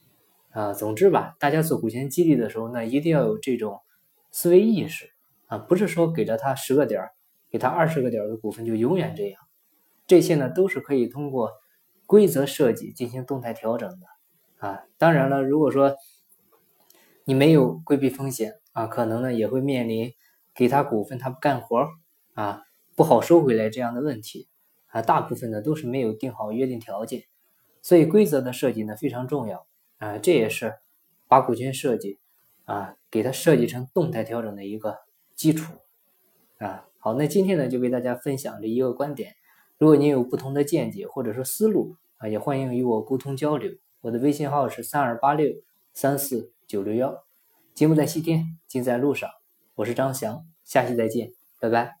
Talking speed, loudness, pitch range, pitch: 275 characters per minute, -23 LUFS, 120-150 Hz, 135 Hz